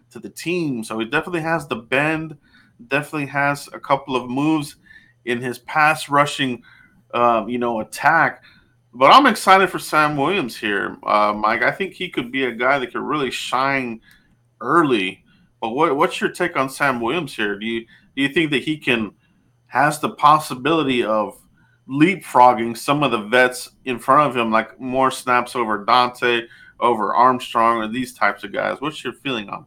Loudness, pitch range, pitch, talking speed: -19 LUFS, 120-150 Hz, 130 Hz, 180 wpm